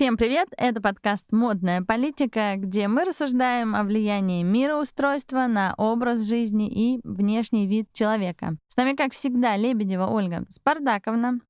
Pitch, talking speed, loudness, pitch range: 225 Hz, 135 wpm, -24 LUFS, 210-250 Hz